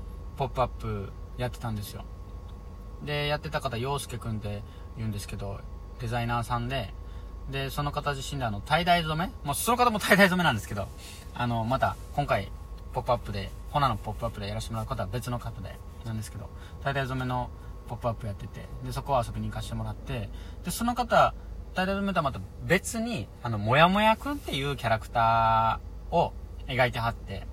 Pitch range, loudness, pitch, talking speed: 100-135 Hz, -29 LUFS, 115 Hz, 400 characters per minute